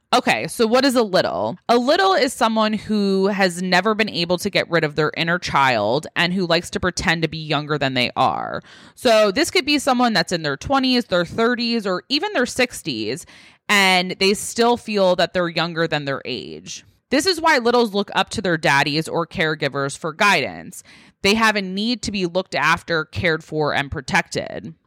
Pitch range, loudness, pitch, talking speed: 165-235 Hz, -19 LUFS, 190 Hz, 200 wpm